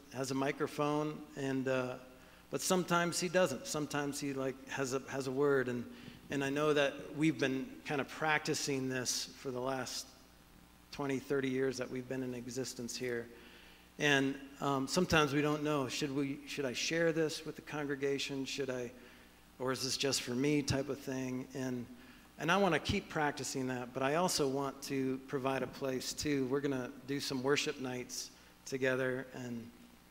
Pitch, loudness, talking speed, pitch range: 135 Hz, -36 LUFS, 185 wpm, 125-145 Hz